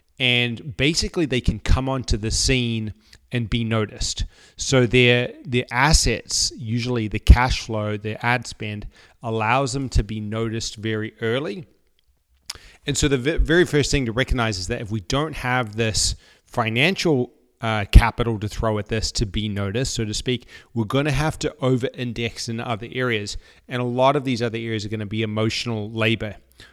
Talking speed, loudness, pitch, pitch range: 180 wpm, -22 LUFS, 115 Hz, 110-130 Hz